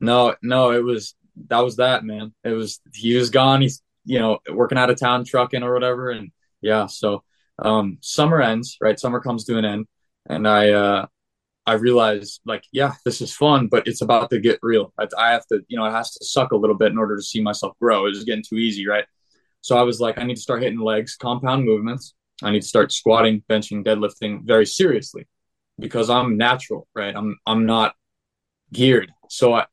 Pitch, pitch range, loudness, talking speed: 115 Hz, 110-125 Hz, -20 LUFS, 215 wpm